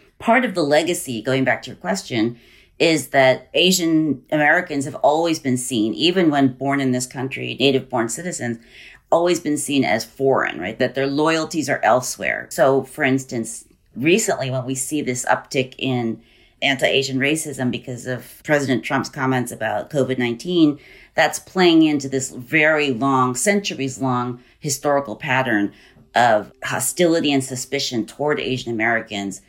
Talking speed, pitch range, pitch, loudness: 155 wpm, 125-150 Hz, 135 Hz, -20 LUFS